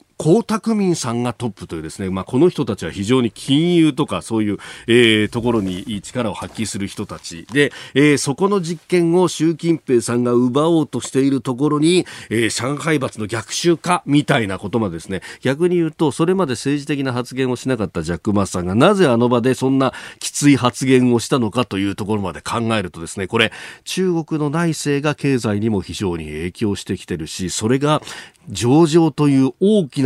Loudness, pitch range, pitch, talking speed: -18 LUFS, 105-150 Hz, 125 Hz, 385 characters per minute